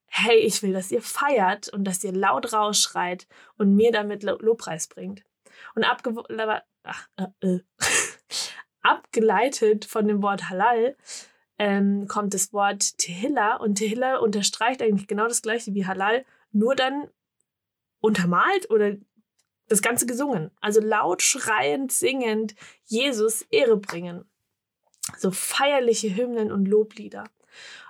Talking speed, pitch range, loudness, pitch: 125 wpm, 200-240 Hz, -23 LUFS, 215 Hz